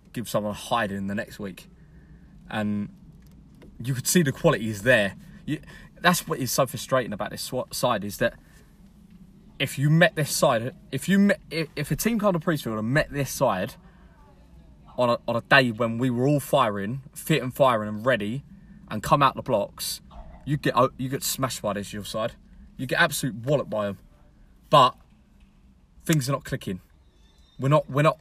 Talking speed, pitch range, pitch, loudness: 190 wpm, 110-160 Hz, 135 Hz, -25 LUFS